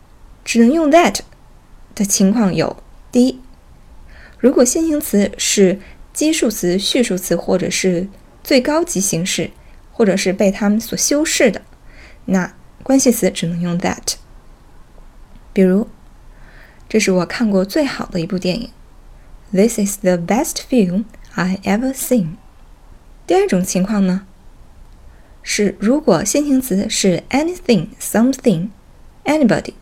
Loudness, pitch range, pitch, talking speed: -16 LUFS, 185-255 Hz, 205 Hz, 265 characters per minute